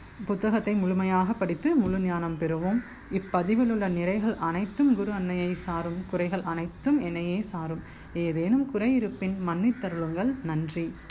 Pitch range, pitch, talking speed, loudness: 170-215 Hz, 190 Hz, 120 wpm, -28 LUFS